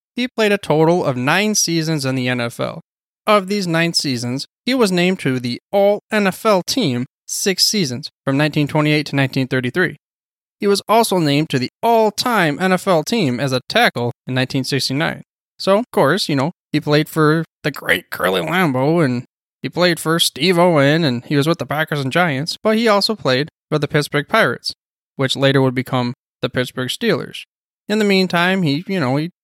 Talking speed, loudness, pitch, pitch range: 185 wpm, -17 LUFS, 155 Hz, 135-190 Hz